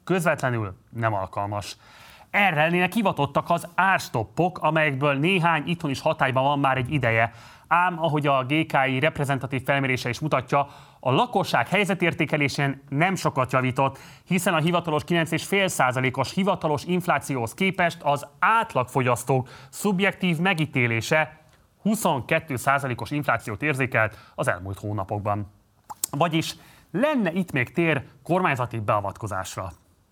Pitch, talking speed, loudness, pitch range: 145 Hz, 110 wpm, -24 LUFS, 125-170 Hz